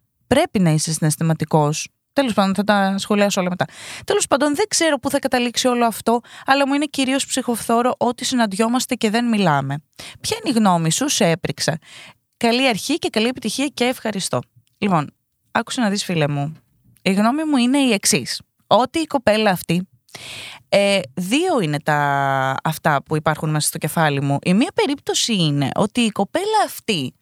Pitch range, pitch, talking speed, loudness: 160-255 Hz, 205 Hz, 175 wpm, -19 LUFS